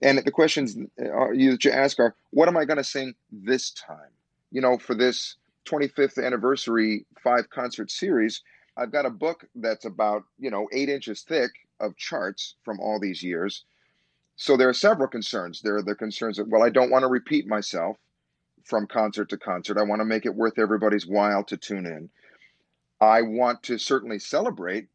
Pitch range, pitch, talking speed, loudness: 105-135 Hz, 115 Hz, 185 wpm, -24 LUFS